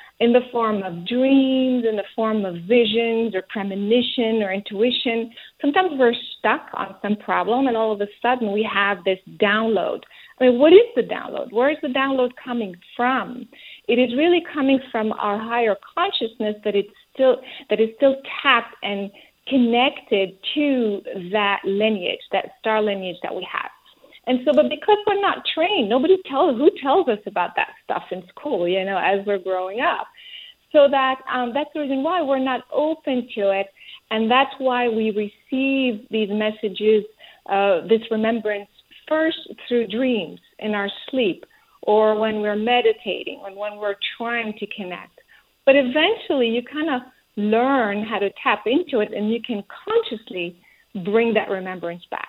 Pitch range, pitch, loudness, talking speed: 210-275 Hz, 235 Hz, -21 LUFS, 165 wpm